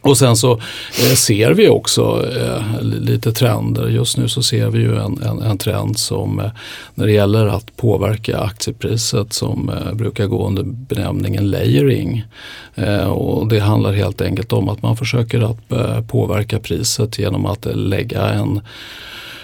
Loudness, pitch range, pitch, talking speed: -16 LUFS, 105-120 Hz, 110 Hz, 145 wpm